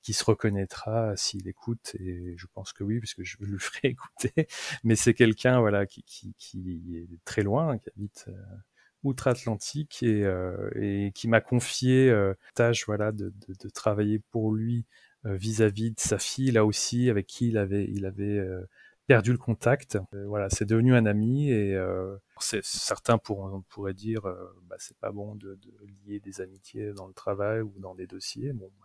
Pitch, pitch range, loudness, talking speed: 105 Hz, 95-115 Hz, -28 LUFS, 195 wpm